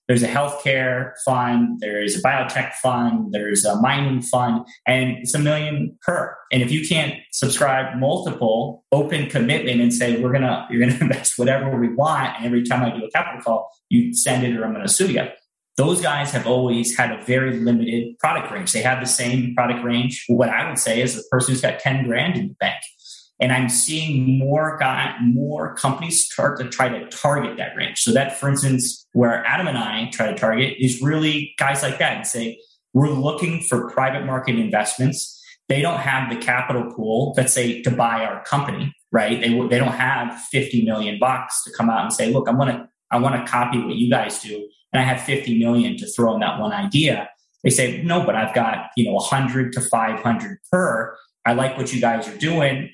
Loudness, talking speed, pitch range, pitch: -20 LUFS, 215 wpm, 120-140 Hz, 125 Hz